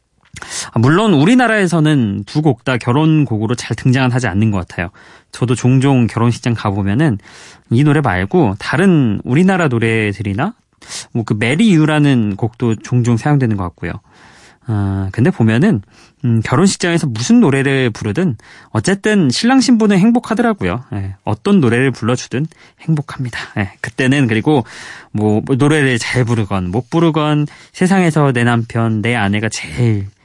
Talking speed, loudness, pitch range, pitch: 315 characters per minute, -14 LUFS, 110-155 Hz, 125 Hz